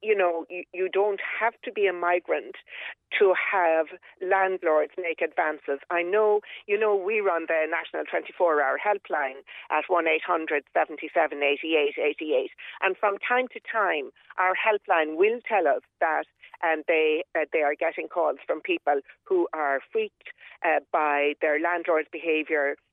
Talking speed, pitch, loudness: 145 wpm, 185 Hz, -26 LUFS